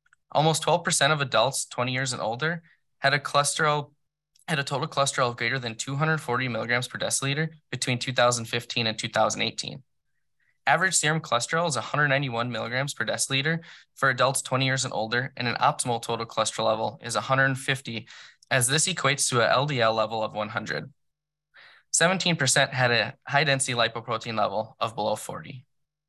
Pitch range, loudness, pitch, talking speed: 115-150 Hz, -25 LUFS, 135 Hz, 150 wpm